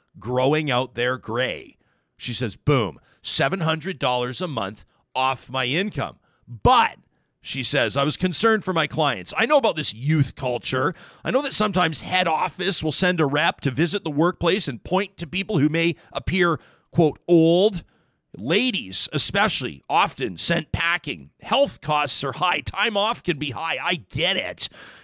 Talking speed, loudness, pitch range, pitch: 165 wpm, -22 LUFS, 135-180 Hz, 160 Hz